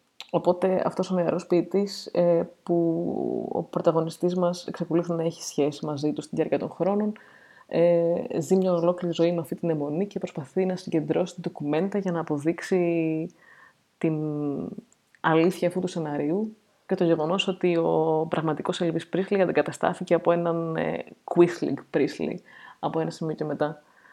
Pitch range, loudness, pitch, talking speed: 160-185 Hz, -26 LUFS, 170 Hz, 145 wpm